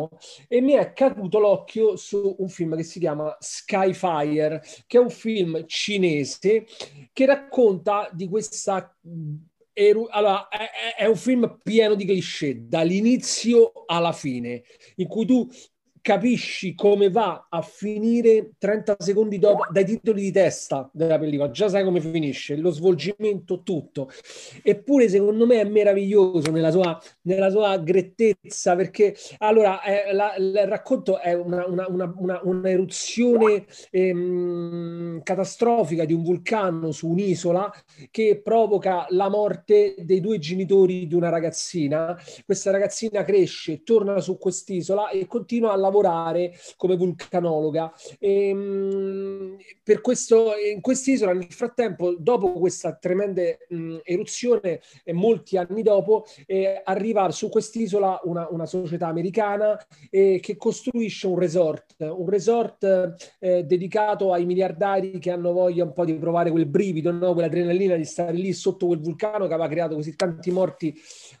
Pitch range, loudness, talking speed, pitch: 175-210 Hz, -22 LUFS, 140 wpm, 190 Hz